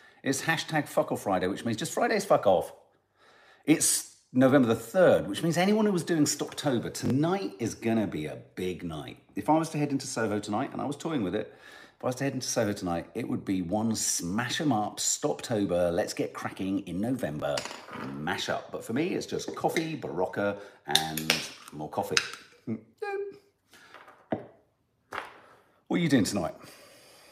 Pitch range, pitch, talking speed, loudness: 95-150 Hz, 115 Hz, 180 wpm, -29 LUFS